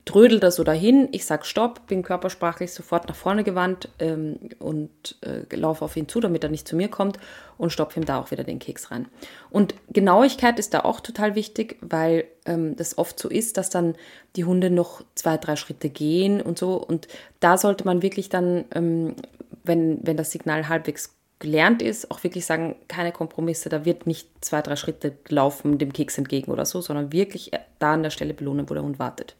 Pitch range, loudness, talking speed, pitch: 155-190 Hz, -23 LUFS, 205 wpm, 170 Hz